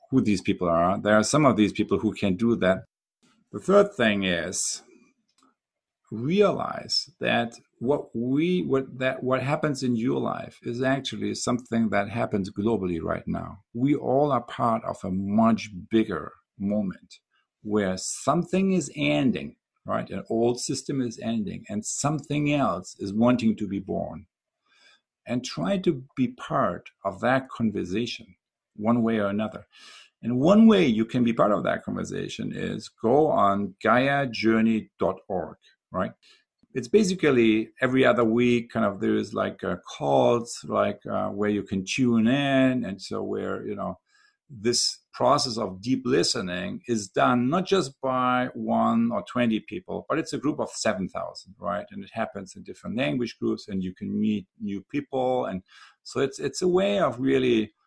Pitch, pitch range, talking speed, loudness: 120 Hz, 105-140 Hz, 160 wpm, -25 LUFS